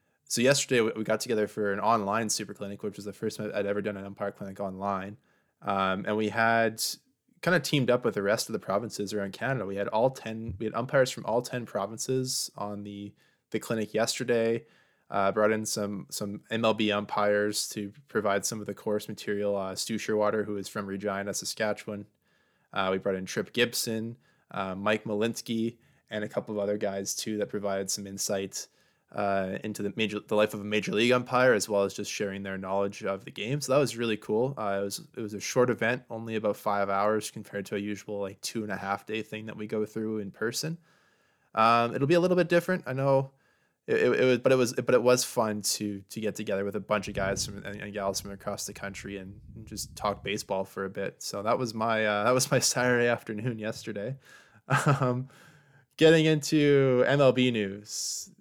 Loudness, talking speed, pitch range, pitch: -29 LUFS, 220 wpm, 100-120 Hz, 105 Hz